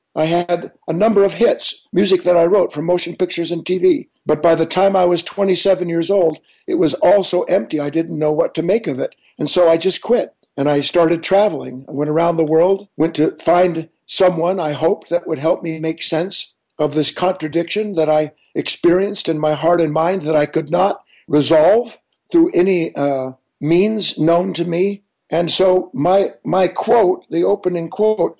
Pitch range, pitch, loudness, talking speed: 160-190 Hz, 170 Hz, -17 LUFS, 200 wpm